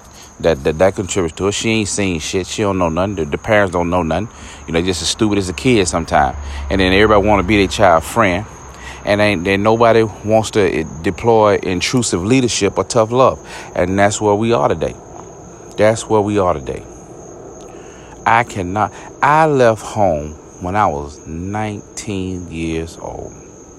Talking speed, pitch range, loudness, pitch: 180 wpm, 90-110 Hz, -15 LUFS, 100 Hz